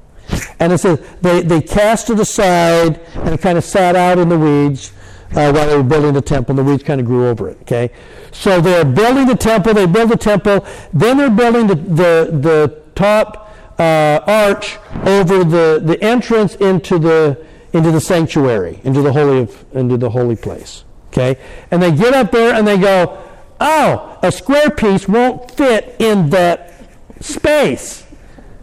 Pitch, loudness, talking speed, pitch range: 175 Hz, -12 LUFS, 180 wpm, 150-210 Hz